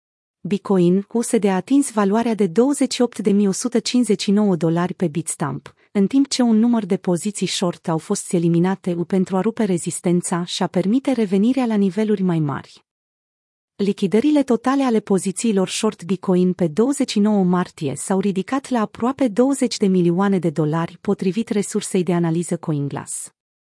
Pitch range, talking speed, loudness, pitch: 180-230 Hz, 140 wpm, -19 LUFS, 200 Hz